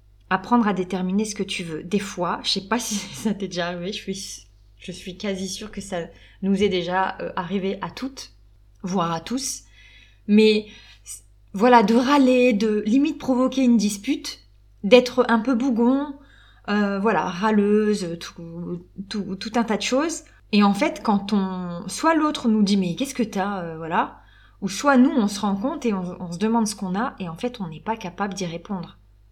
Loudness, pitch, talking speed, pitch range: -22 LUFS, 200 Hz, 195 wpm, 180-230 Hz